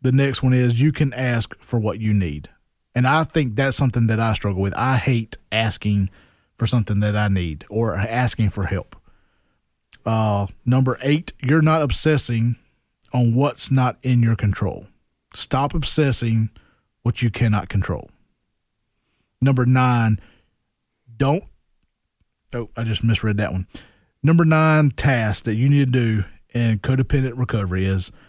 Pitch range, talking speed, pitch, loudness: 105-130 Hz, 150 wpm, 115 Hz, -20 LUFS